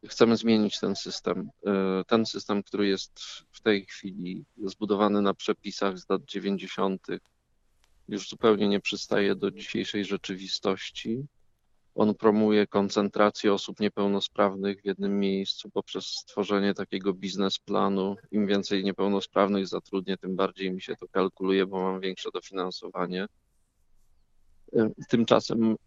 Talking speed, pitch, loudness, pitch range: 120 wpm, 100 Hz, -28 LUFS, 95-105 Hz